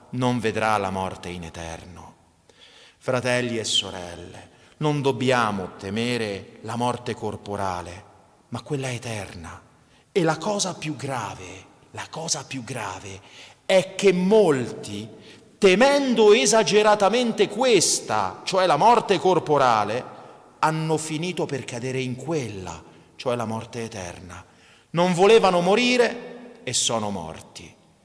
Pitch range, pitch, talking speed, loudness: 100-170 Hz, 125 Hz, 115 wpm, -22 LUFS